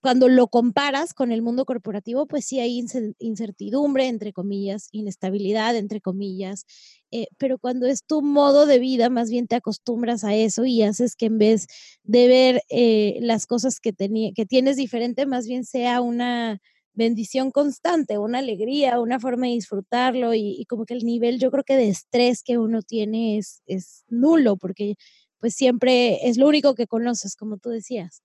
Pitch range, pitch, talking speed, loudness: 215-255 Hz, 235 Hz, 180 wpm, -21 LUFS